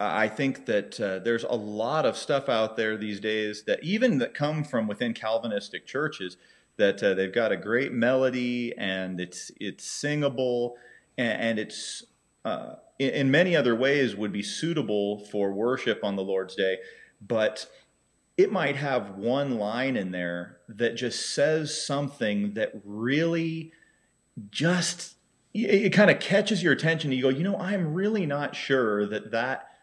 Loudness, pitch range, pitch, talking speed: -27 LUFS, 105-160 Hz, 125 Hz, 165 wpm